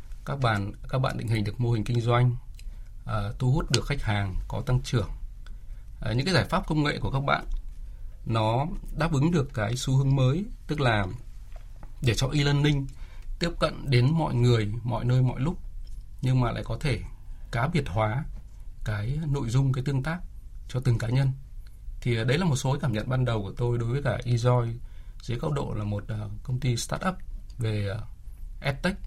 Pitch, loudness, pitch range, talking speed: 120 Hz, -27 LUFS, 105-135 Hz, 200 wpm